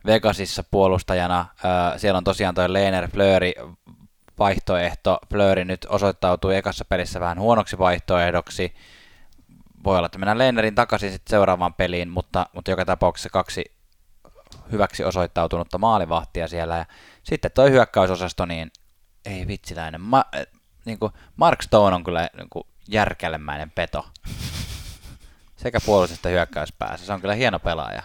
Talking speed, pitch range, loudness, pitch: 130 wpm, 85-100 Hz, -22 LUFS, 90 Hz